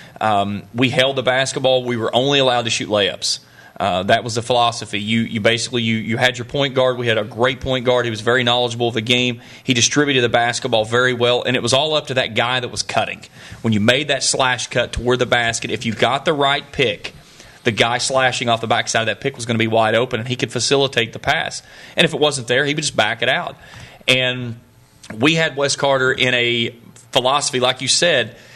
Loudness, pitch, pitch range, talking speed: -17 LUFS, 125 Hz, 115-130 Hz, 240 wpm